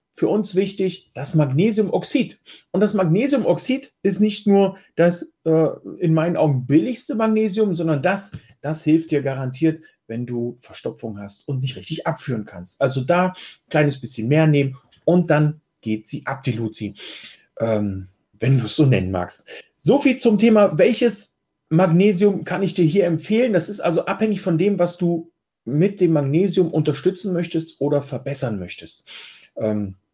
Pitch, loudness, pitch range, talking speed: 160 Hz, -20 LUFS, 130-190 Hz, 160 wpm